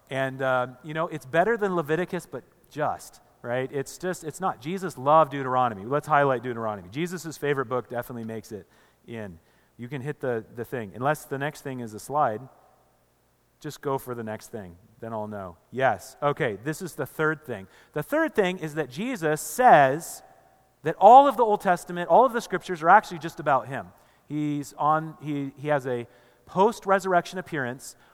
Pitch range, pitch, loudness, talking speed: 125-170 Hz, 145 Hz, -25 LUFS, 185 wpm